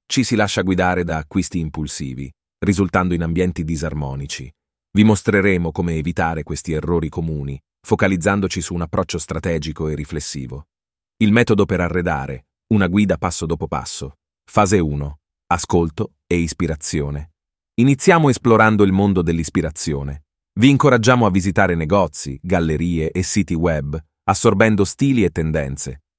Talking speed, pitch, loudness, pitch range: 130 wpm, 85 Hz, -18 LUFS, 75-100 Hz